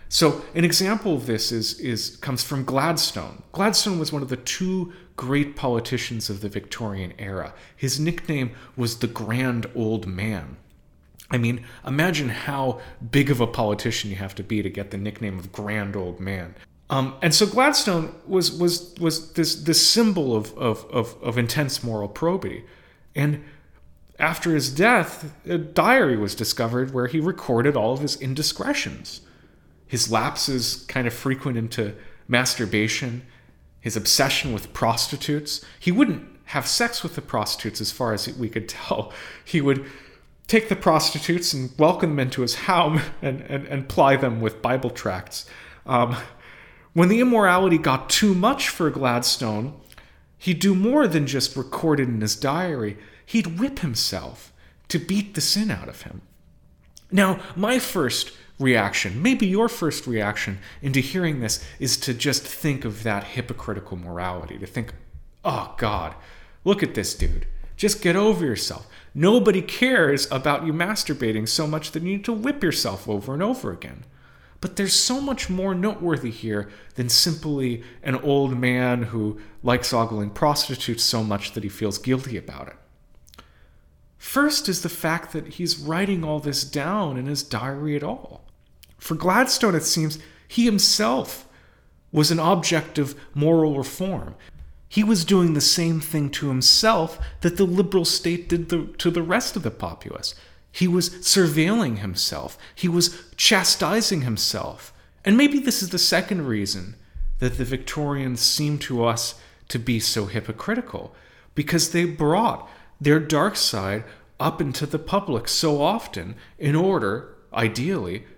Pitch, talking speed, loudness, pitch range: 140 Hz, 160 wpm, -22 LUFS, 115-170 Hz